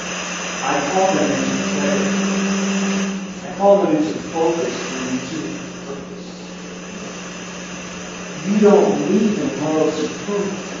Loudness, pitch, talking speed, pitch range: -19 LUFS, 190 Hz, 105 wpm, 155-195 Hz